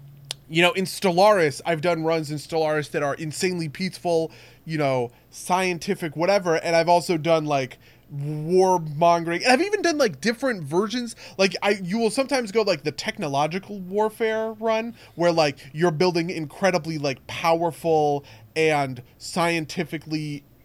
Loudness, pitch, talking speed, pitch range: -23 LUFS, 170 Hz, 150 wpm, 150-190 Hz